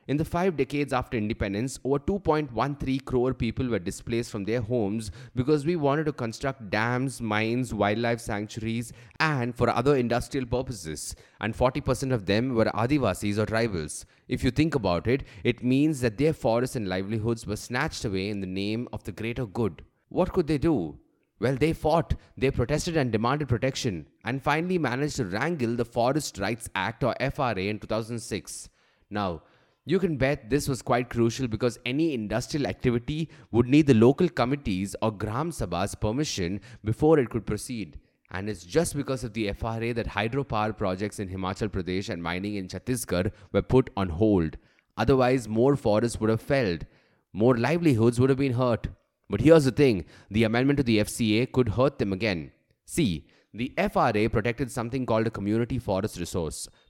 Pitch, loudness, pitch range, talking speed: 120 Hz, -27 LUFS, 105-135 Hz, 175 wpm